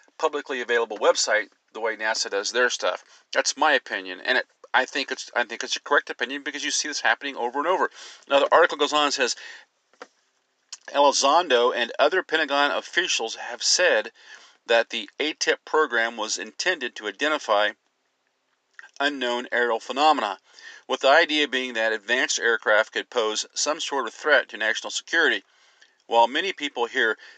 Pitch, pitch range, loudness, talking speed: 130 Hz, 115-150 Hz, -23 LUFS, 165 wpm